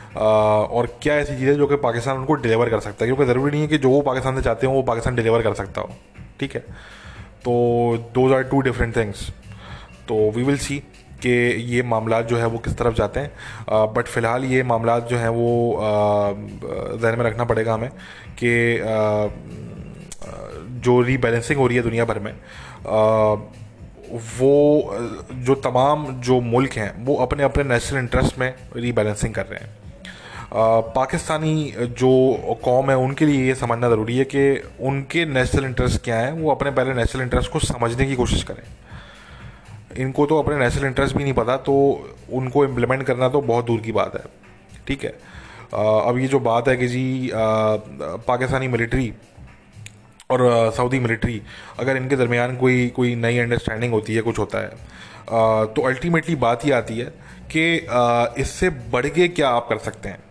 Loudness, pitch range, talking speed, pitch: -20 LUFS, 115-130 Hz, 175 wpm, 120 Hz